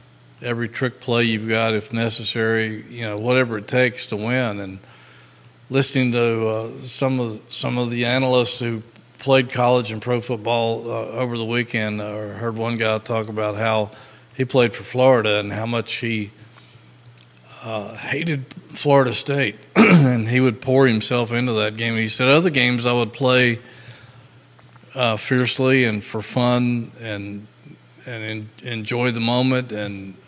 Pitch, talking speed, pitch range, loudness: 120 Hz, 160 wpm, 110-125 Hz, -20 LUFS